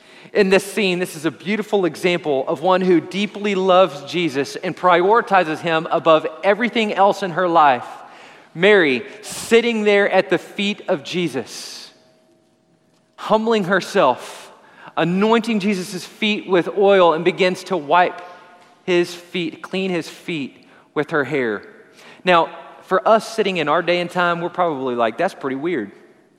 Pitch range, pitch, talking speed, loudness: 170-200 Hz, 180 Hz, 150 wpm, -18 LUFS